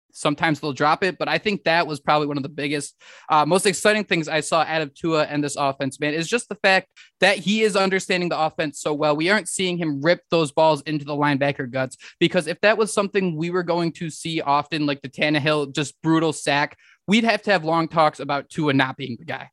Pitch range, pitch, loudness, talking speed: 145-180 Hz, 160 Hz, -21 LUFS, 245 wpm